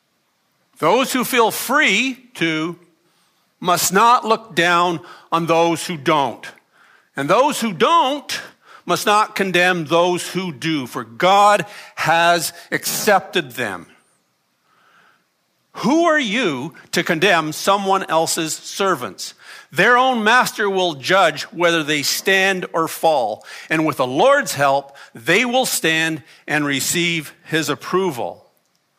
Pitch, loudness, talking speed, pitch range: 175 Hz, -17 LUFS, 120 wpm, 165-210 Hz